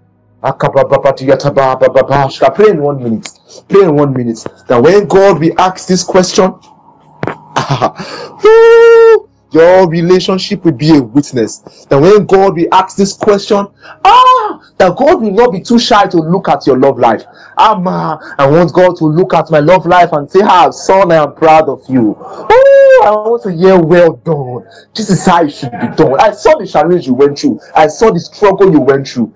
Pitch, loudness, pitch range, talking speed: 180 Hz, -8 LUFS, 150-200 Hz, 180 wpm